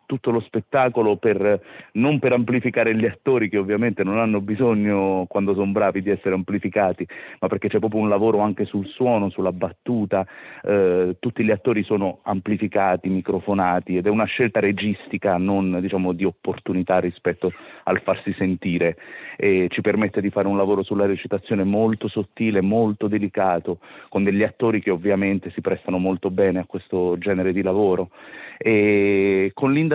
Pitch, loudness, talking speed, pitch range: 100 Hz, -21 LUFS, 160 wpm, 95-110 Hz